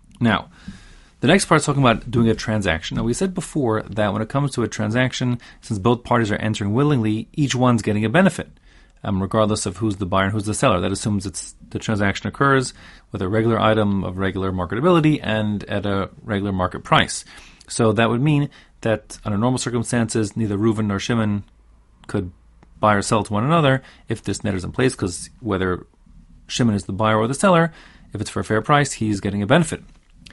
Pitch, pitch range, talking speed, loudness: 110 Hz, 100-125 Hz, 210 wpm, -20 LUFS